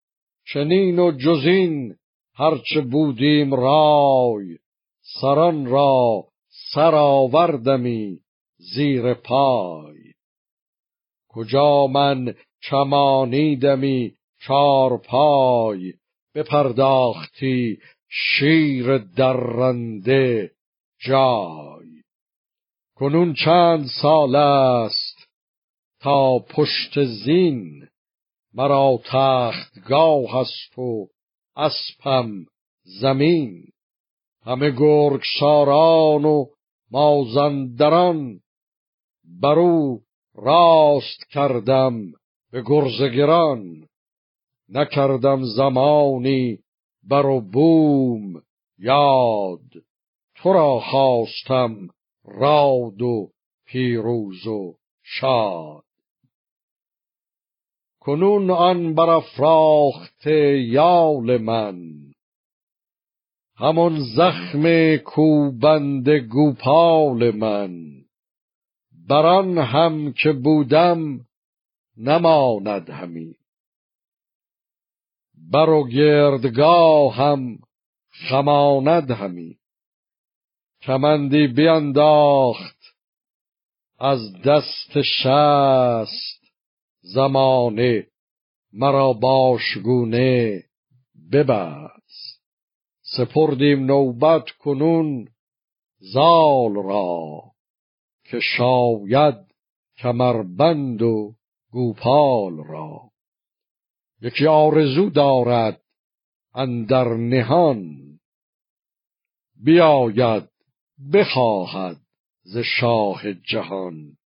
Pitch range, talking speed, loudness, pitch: 120-150 Hz, 60 wpm, -18 LUFS, 135 Hz